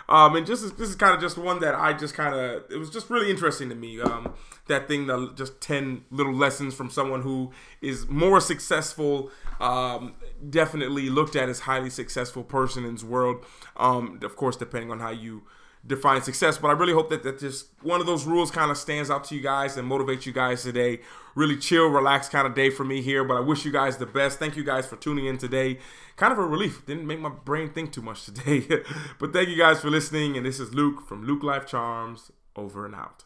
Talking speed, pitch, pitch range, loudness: 235 wpm, 140 Hz, 130-150 Hz, -25 LUFS